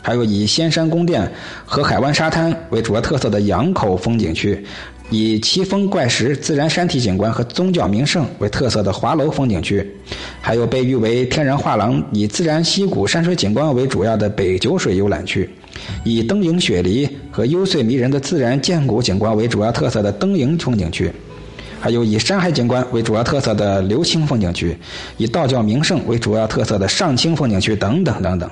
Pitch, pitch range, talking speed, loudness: 115 Hz, 105-155 Hz, 300 characters per minute, -17 LUFS